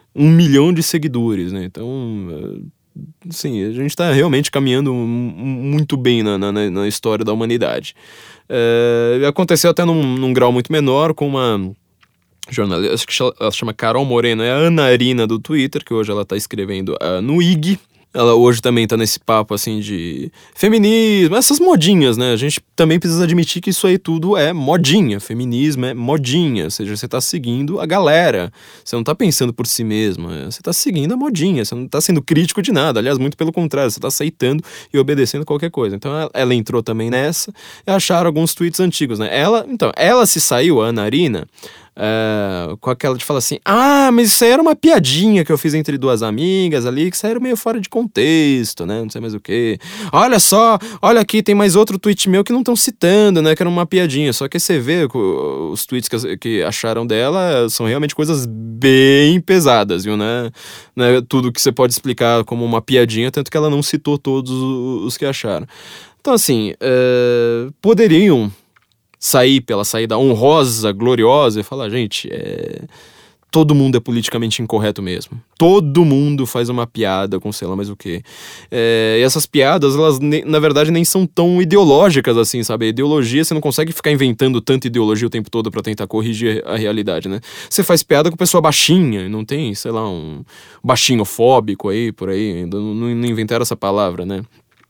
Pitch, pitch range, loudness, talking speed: 135 Hz, 115-165 Hz, -15 LUFS, 190 wpm